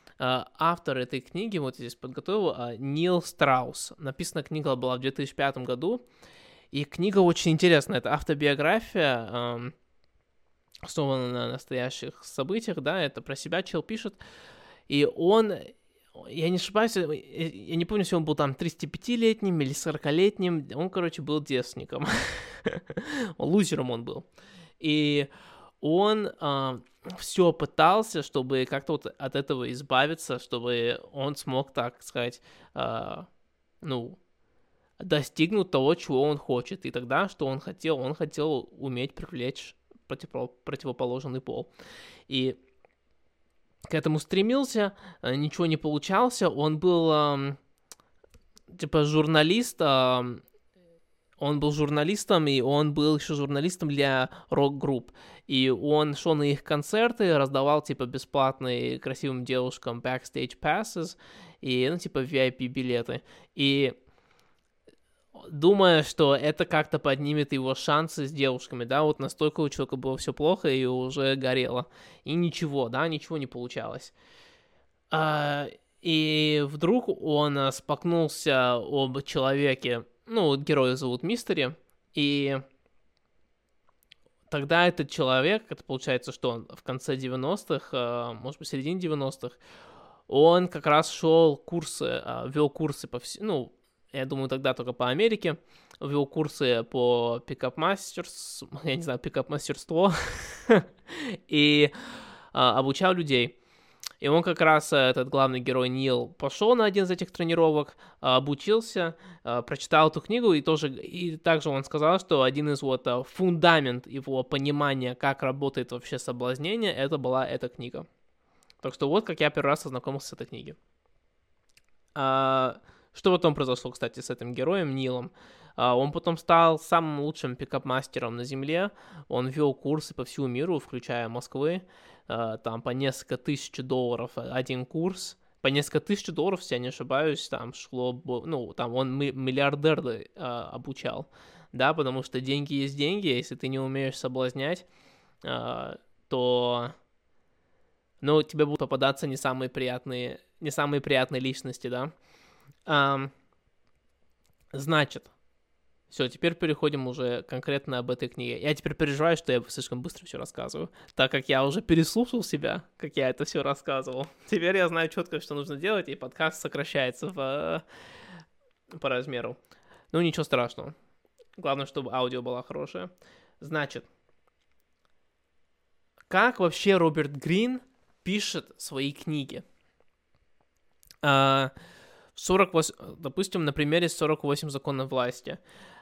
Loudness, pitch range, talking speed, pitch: -27 LUFS, 130-165 Hz, 125 wpm, 145 Hz